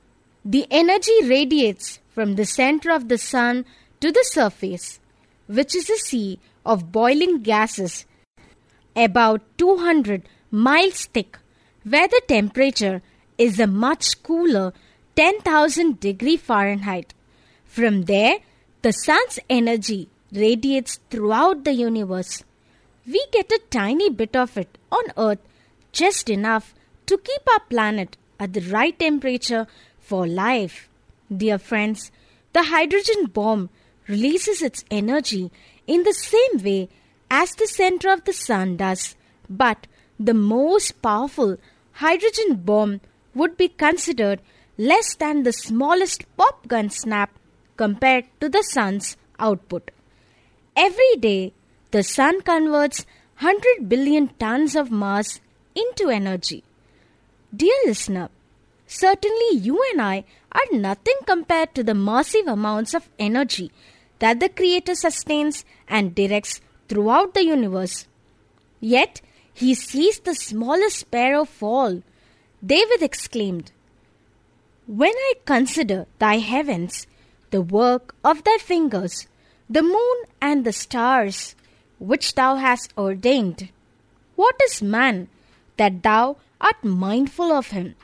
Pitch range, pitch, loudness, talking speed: 210-330 Hz, 250 Hz, -20 LUFS, 120 wpm